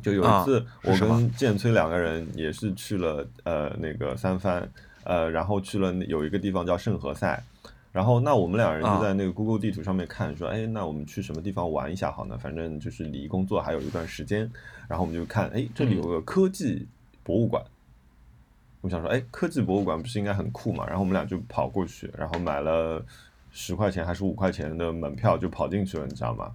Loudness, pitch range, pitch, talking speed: -28 LUFS, 80-105 Hz, 95 Hz, 335 characters per minute